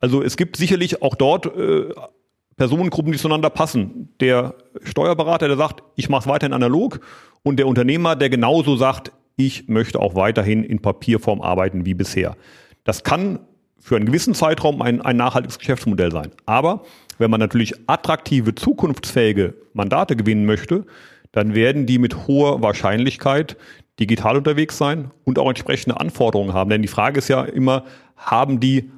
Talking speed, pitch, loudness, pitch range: 160 wpm, 130 Hz, -19 LUFS, 110-150 Hz